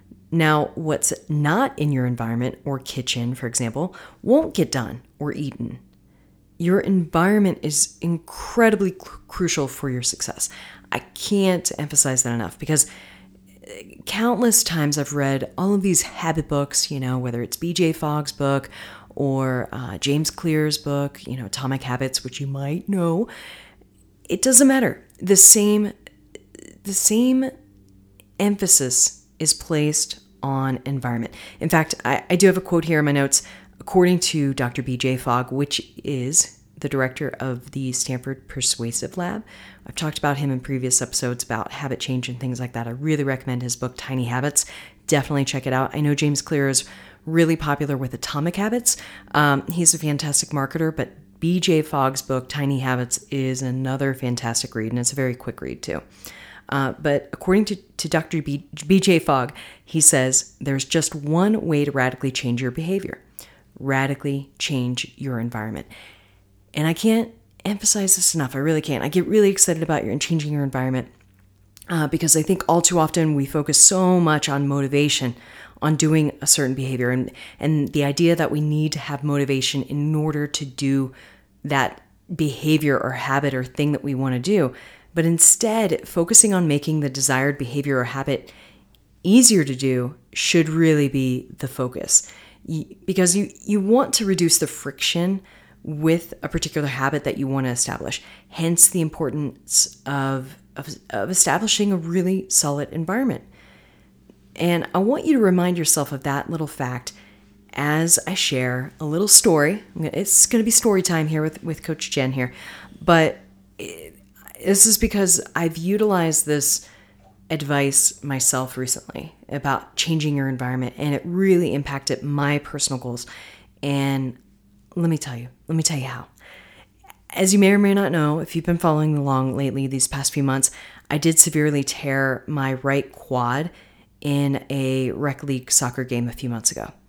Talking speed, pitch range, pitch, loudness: 165 wpm, 130-165 Hz, 145 Hz, -20 LUFS